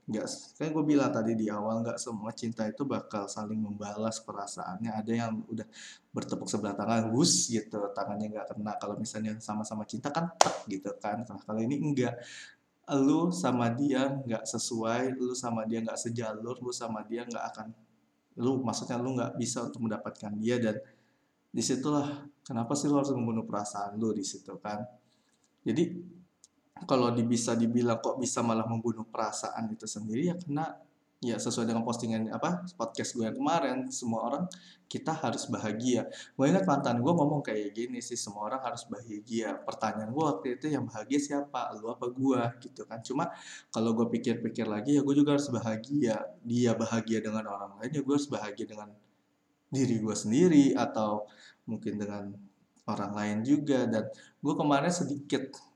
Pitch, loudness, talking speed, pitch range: 115 Hz, -32 LUFS, 165 wpm, 110-130 Hz